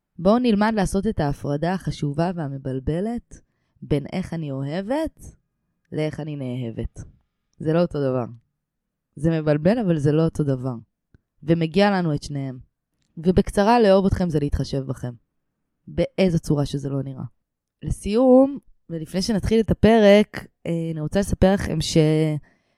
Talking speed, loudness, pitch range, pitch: 135 wpm, -22 LUFS, 145-190 Hz, 160 Hz